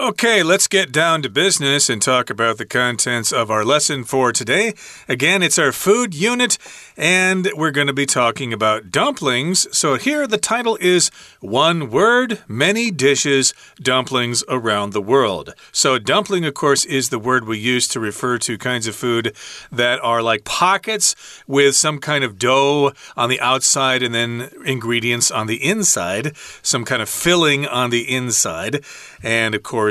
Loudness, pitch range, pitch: -17 LUFS, 120-175 Hz, 135 Hz